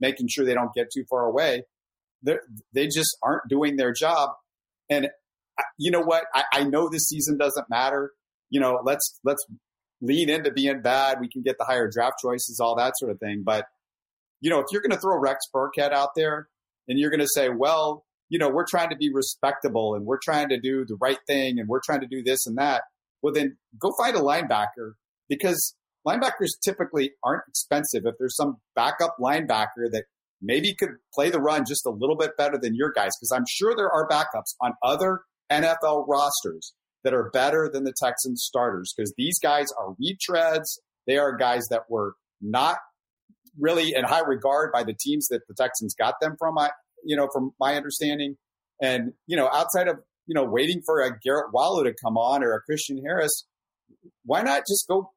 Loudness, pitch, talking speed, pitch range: -25 LUFS, 140 Hz, 205 wpm, 125-150 Hz